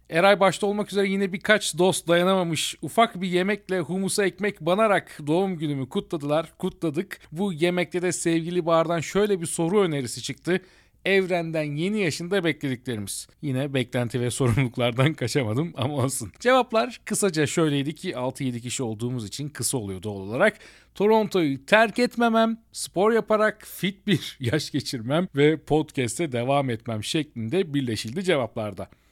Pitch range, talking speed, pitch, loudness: 135-195 Hz, 140 wpm, 165 Hz, -24 LUFS